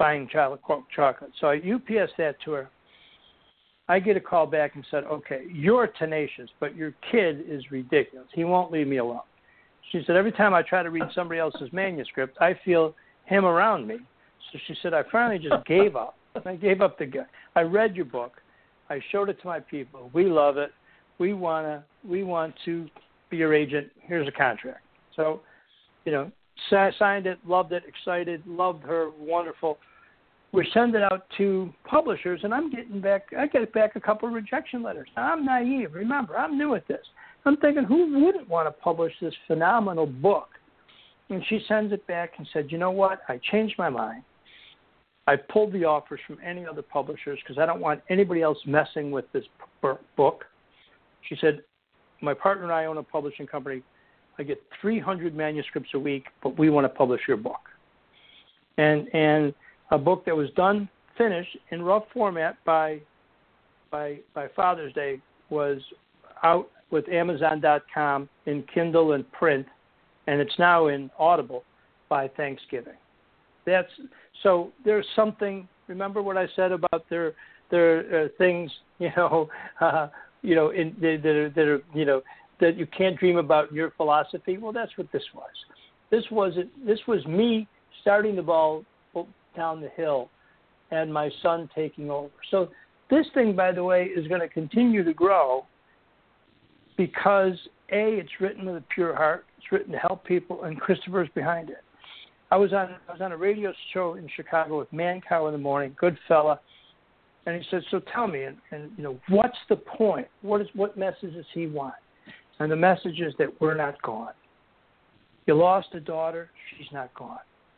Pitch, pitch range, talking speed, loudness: 170 Hz, 155-195 Hz, 175 wpm, -25 LUFS